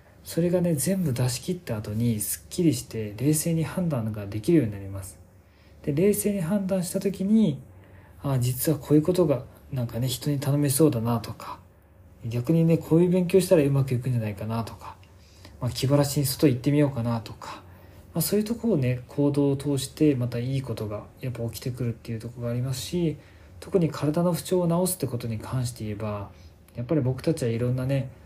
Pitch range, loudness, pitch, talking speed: 110-160 Hz, -26 LUFS, 130 Hz, 410 characters per minute